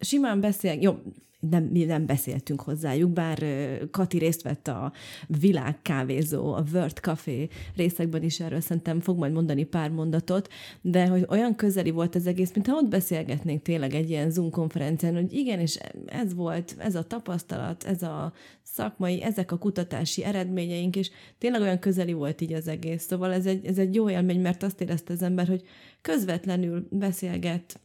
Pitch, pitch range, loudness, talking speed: 175 Hz, 160-185 Hz, -27 LUFS, 170 wpm